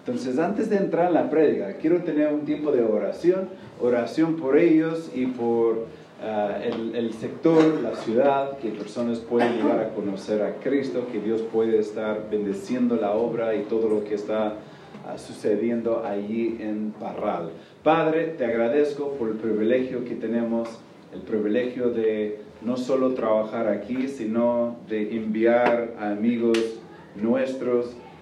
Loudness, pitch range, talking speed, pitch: -24 LUFS, 110-130 Hz, 150 wpm, 115 Hz